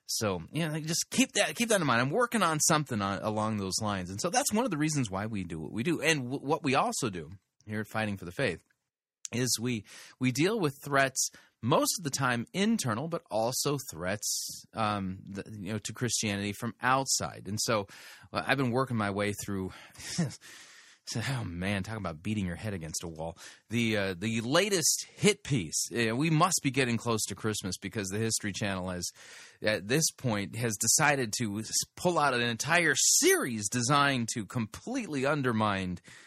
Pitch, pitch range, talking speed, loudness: 115 Hz, 100-145 Hz, 195 wpm, -30 LUFS